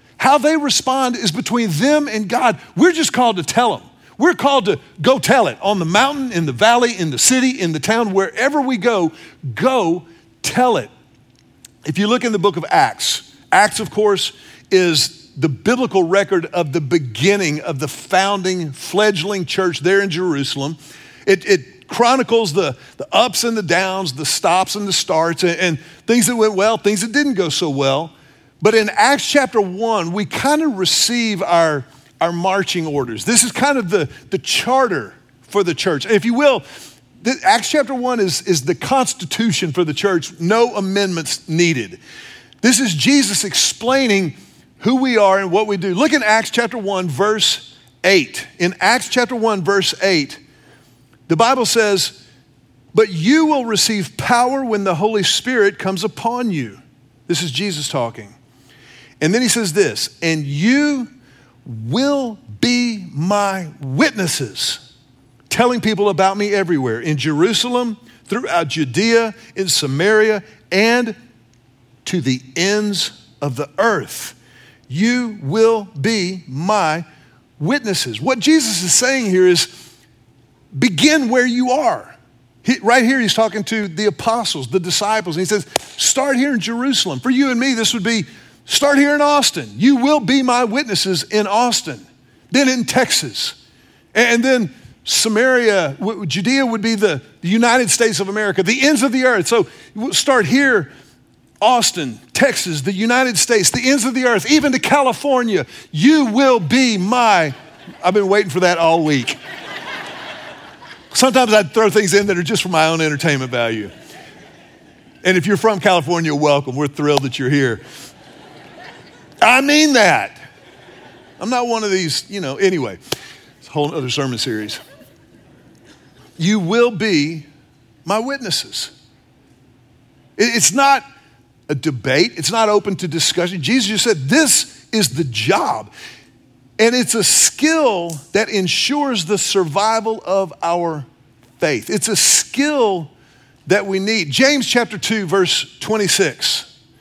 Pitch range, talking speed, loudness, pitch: 165-240 Hz, 155 wpm, -16 LUFS, 200 Hz